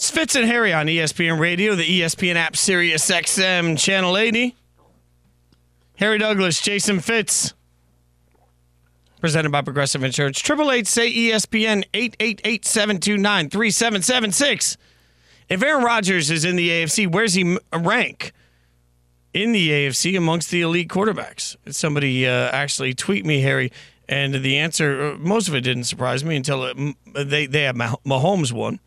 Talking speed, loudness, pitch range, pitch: 135 wpm, -19 LUFS, 130-205 Hz, 165 Hz